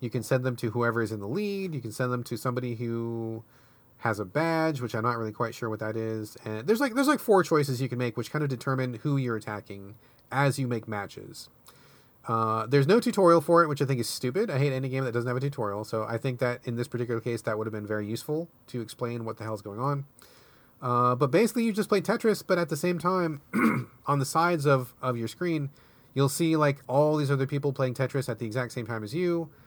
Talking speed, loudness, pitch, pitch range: 255 wpm, -28 LUFS, 125 Hz, 115-150 Hz